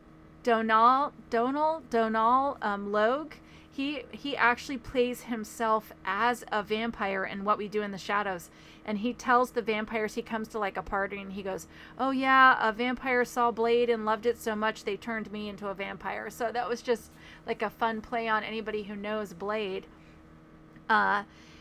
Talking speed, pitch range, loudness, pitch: 180 wpm, 205-240 Hz, -29 LUFS, 220 Hz